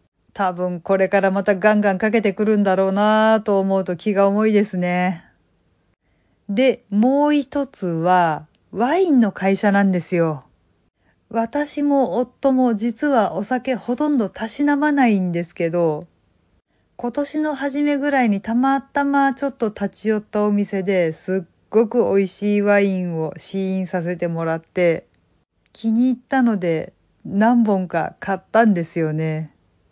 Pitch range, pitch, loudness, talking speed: 175-240 Hz, 200 Hz, -19 LUFS, 275 characters per minute